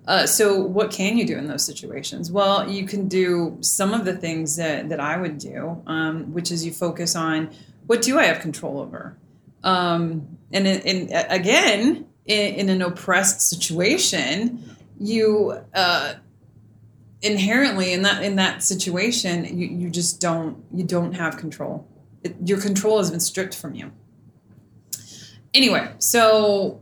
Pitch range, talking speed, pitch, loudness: 170-205 Hz, 155 wpm, 185 Hz, -21 LUFS